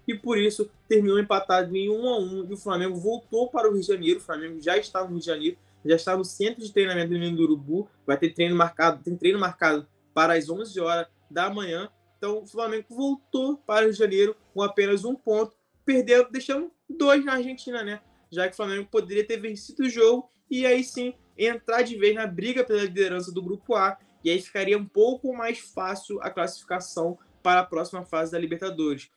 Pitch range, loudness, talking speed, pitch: 175-230 Hz, -25 LUFS, 220 wpm, 200 Hz